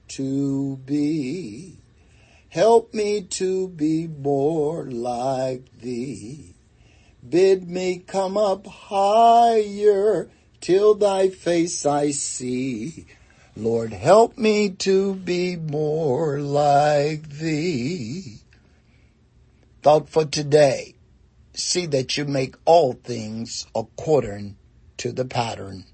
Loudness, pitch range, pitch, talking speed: -21 LUFS, 130-190 Hz, 150 Hz, 95 wpm